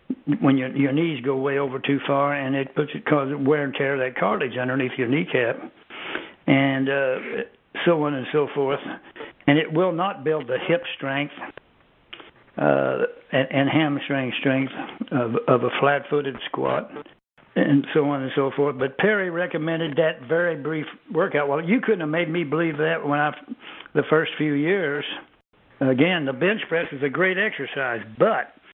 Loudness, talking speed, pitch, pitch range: -23 LUFS, 175 wpm, 145 Hz, 135-165 Hz